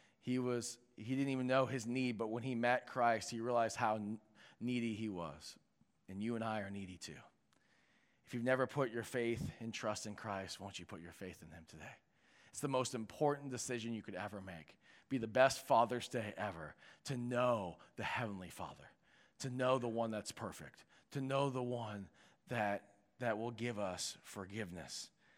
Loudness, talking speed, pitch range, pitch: -40 LUFS, 190 wpm, 100-125 Hz, 115 Hz